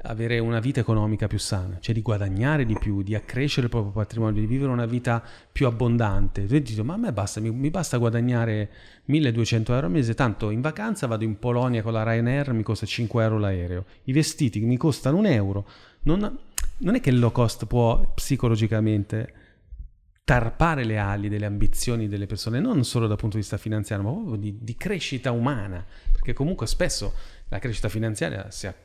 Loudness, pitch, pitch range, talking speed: -25 LUFS, 115 Hz, 105-125 Hz, 195 wpm